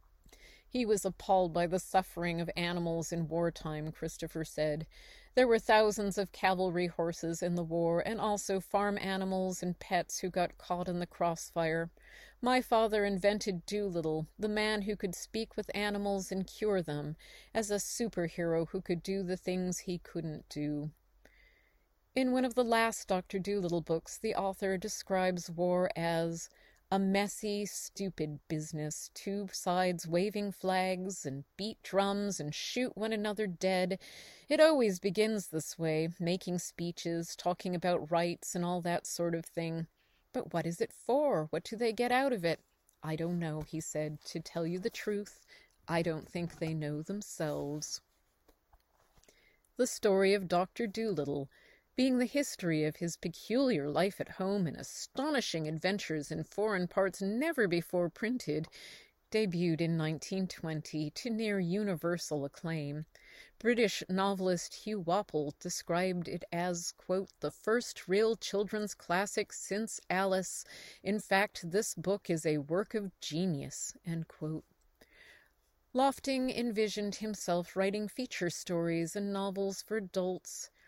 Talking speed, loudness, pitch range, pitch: 145 wpm, -34 LUFS, 165-205 Hz, 185 Hz